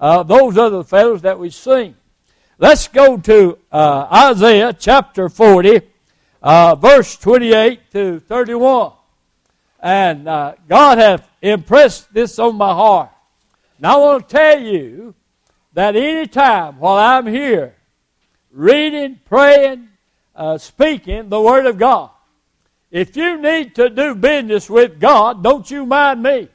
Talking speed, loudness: 135 wpm, -11 LUFS